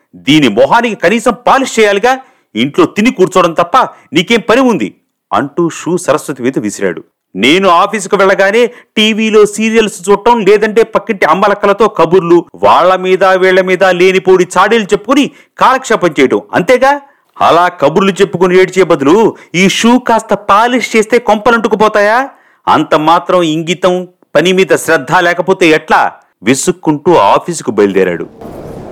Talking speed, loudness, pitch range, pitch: 115 wpm, -9 LUFS, 175-225 Hz, 195 Hz